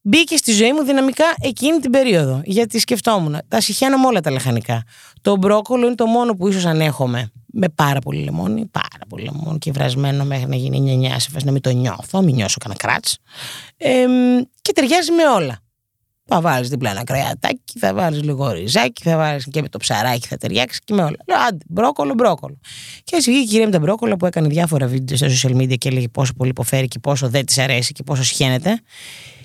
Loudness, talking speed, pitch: -17 LUFS, 205 wpm, 150 Hz